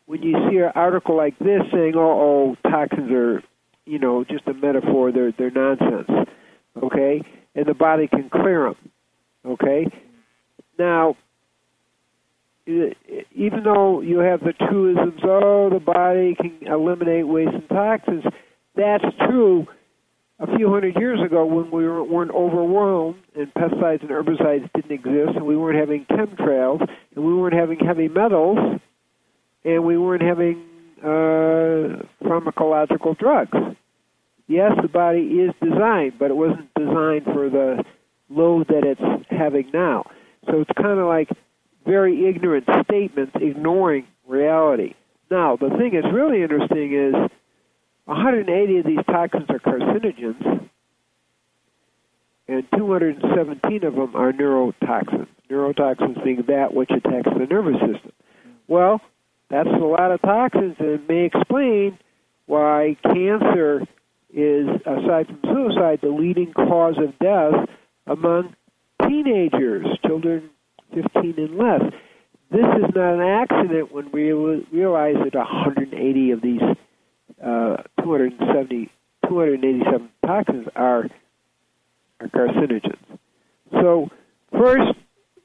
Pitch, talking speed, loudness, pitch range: 160 Hz, 125 wpm, -19 LUFS, 140-180 Hz